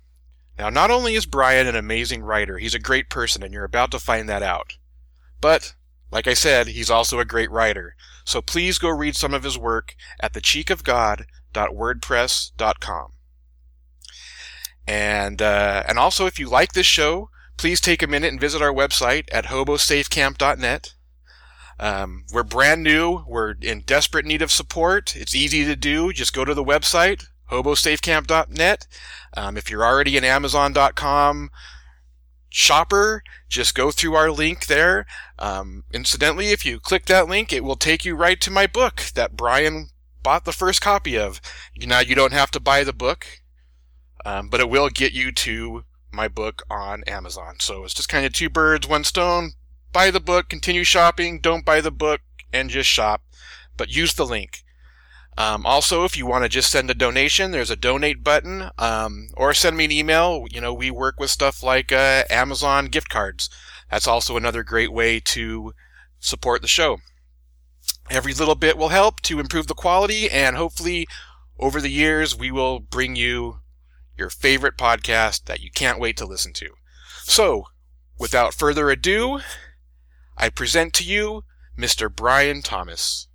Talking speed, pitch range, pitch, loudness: 170 wpm, 95-155 Hz, 130 Hz, -19 LUFS